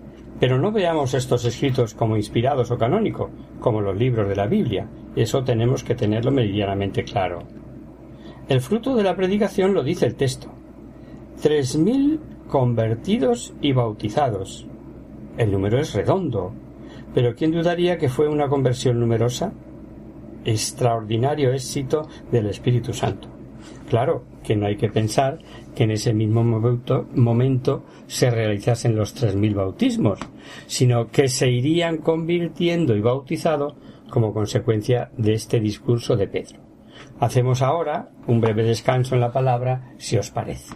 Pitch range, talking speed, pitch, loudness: 115-145 Hz, 140 wpm, 125 Hz, -21 LUFS